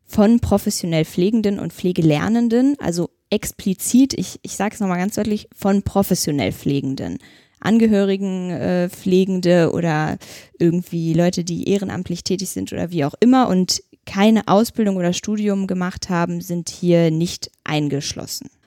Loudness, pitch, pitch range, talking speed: -19 LUFS, 185 Hz, 170-205 Hz, 135 wpm